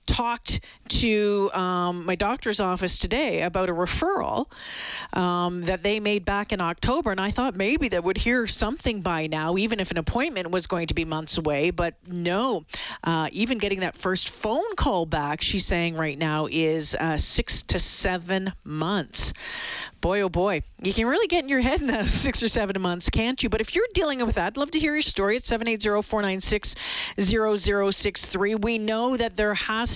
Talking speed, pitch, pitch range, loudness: 190 wpm, 200 Hz, 175-225 Hz, -24 LUFS